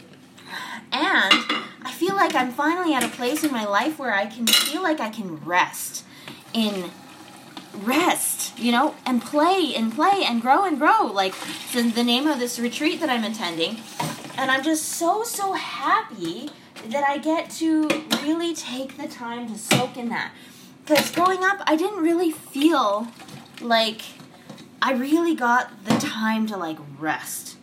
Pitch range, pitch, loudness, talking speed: 230-315 Hz, 260 Hz, -22 LUFS, 165 wpm